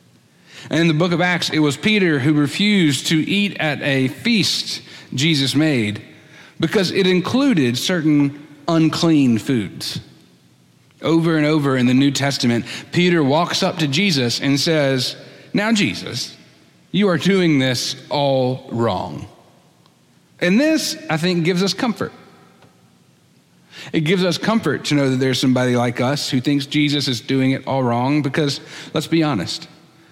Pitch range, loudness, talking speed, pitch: 135-175 Hz, -18 LUFS, 150 wpm, 150 Hz